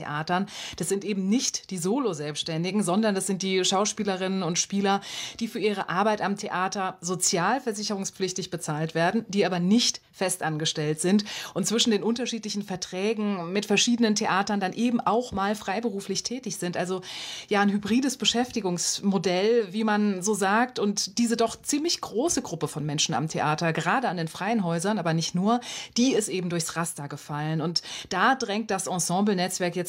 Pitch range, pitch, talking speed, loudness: 180-215 Hz, 195 Hz, 170 wpm, -26 LUFS